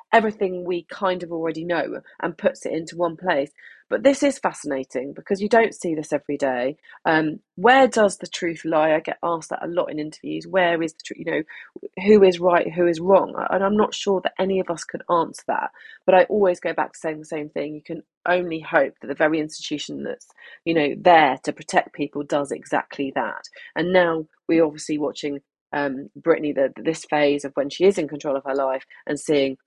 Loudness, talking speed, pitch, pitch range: -22 LUFS, 220 wpm, 165 Hz, 150-185 Hz